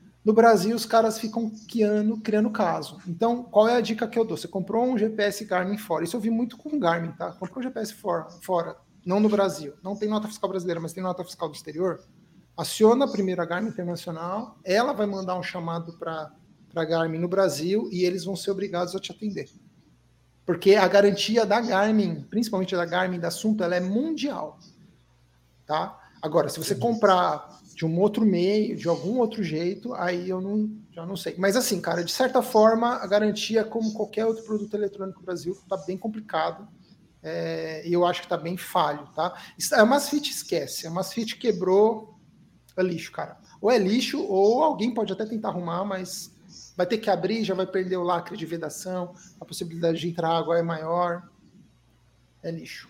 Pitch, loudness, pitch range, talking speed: 190 Hz, -25 LUFS, 175-215 Hz, 195 wpm